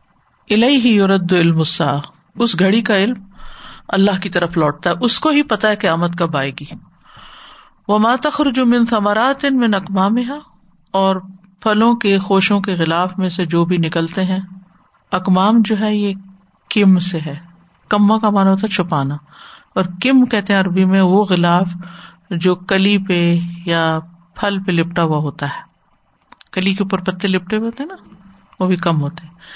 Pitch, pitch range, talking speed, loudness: 190 Hz, 175-210 Hz, 175 wpm, -16 LUFS